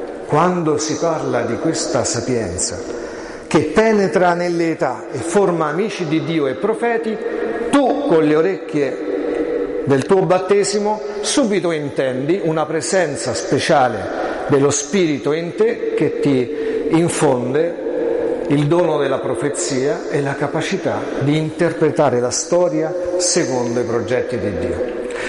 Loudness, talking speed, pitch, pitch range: -18 LUFS, 120 wpm, 170 Hz, 150-205 Hz